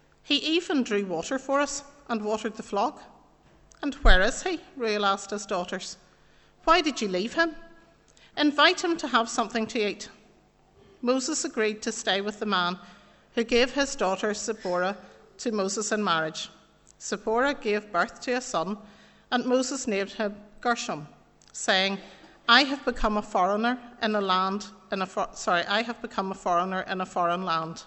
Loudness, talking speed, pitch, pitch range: -27 LUFS, 170 wpm, 220 Hz, 190-250 Hz